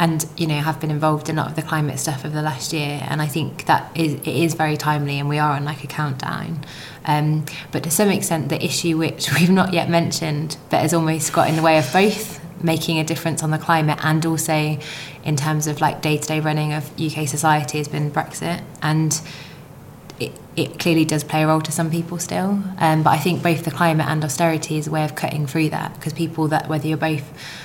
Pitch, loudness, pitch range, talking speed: 155 Hz, -20 LUFS, 150-165 Hz, 235 wpm